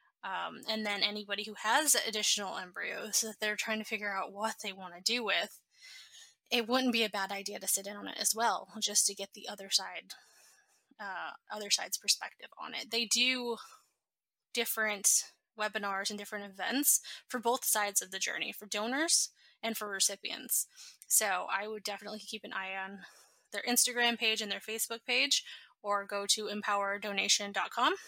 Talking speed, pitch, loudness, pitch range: 175 wpm, 215 Hz, -32 LUFS, 200-230 Hz